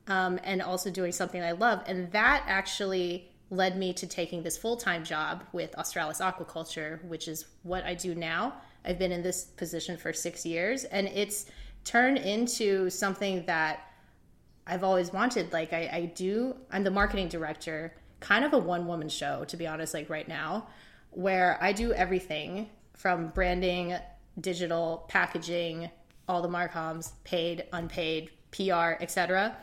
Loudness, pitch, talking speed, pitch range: -31 LUFS, 180 Hz, 155 wpm, 165-190 Hz